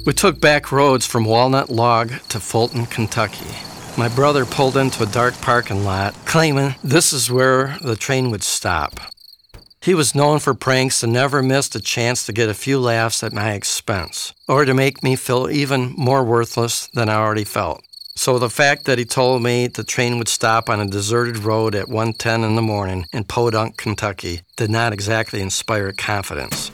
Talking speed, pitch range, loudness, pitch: 190 wpm, 110-135 Hz, -18 LUFS, 120 Hz